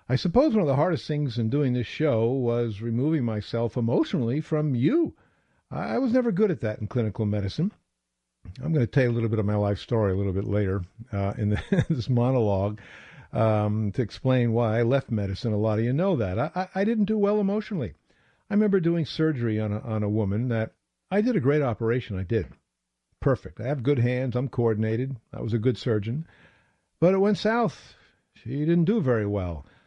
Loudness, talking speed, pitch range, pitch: -26 LUFS, 210 wpm, 105-155 Hz, 120 Hz